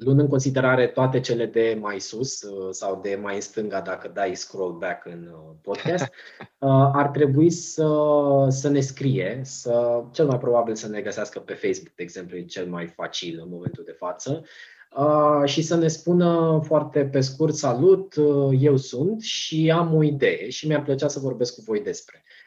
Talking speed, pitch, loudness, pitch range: 175 wpm, 140 Hz, -23 LUFS, 120-155 Hz